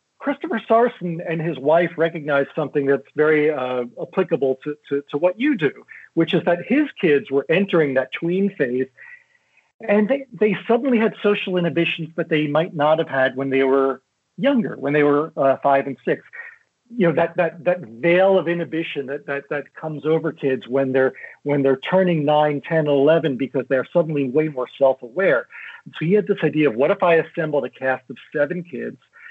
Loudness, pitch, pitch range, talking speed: -20 LUFS, 160 Hz, 140-180 Hz, 195 wpm